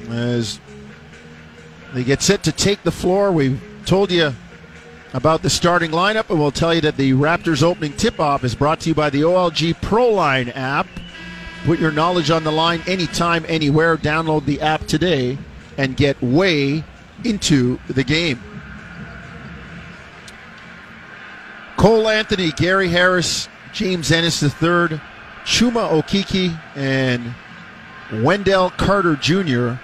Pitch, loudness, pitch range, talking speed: 160 Hz, -17 LUFS, 135-175 Hz, 135 wpm